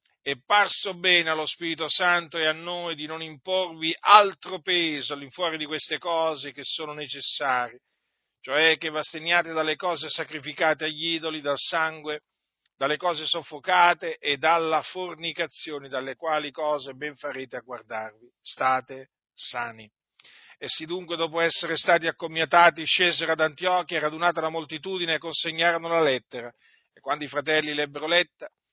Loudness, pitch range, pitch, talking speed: -23 LUFS, 150-170 Hz, 160 Hz, 145 wpm